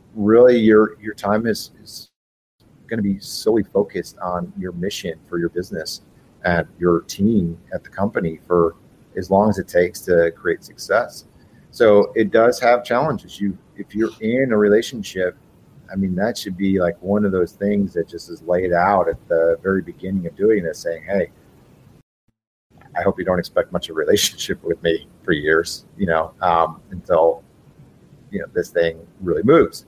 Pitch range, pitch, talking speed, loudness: 90-105 Hz, 95 Hz, 180 wpm, -19 LUFS